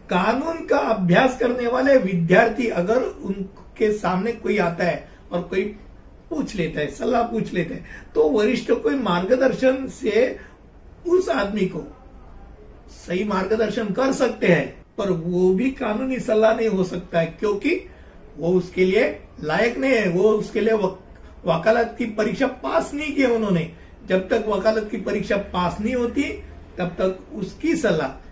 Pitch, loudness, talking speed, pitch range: 215 Hz, -22 LUFS, 155 wpm, 185-245 Hz